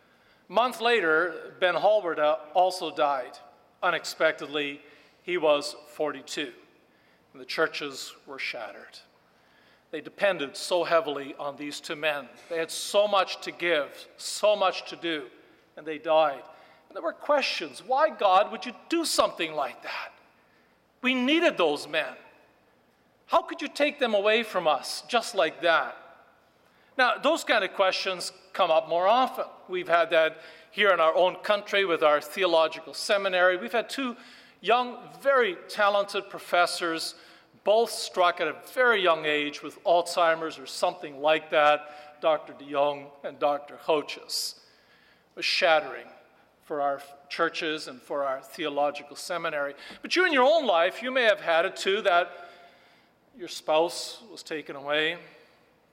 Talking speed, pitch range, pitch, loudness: 150 wpm, 155-220 Hz, 175 Hz, -26 LUFS